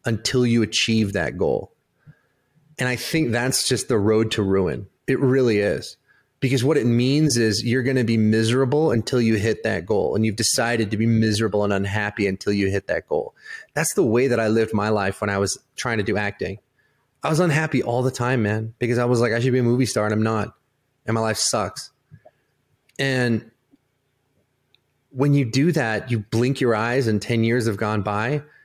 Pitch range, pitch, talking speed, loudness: 110-135 Hz, 120 Hz, 205 wpm, -21 LUFS